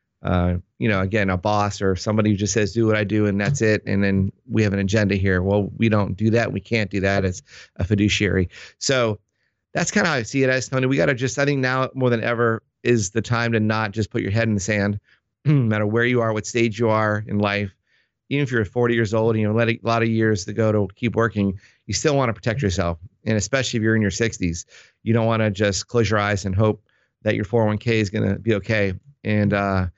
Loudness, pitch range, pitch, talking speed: -21 LUFS, 100-115 Hz, 110 Hz, 260 wpm